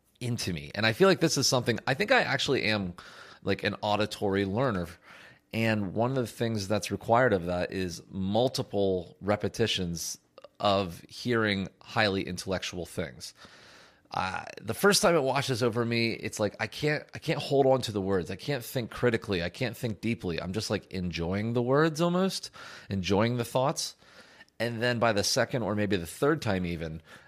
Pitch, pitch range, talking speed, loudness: 110 Hz, 95-125 Hz, 185 wpm, -29 LUFS